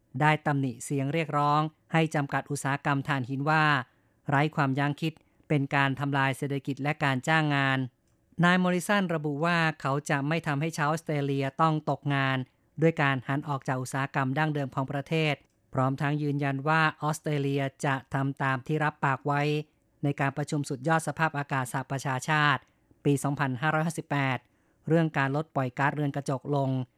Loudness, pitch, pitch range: -28 LUFS, 145 Hz, 135-155 Hz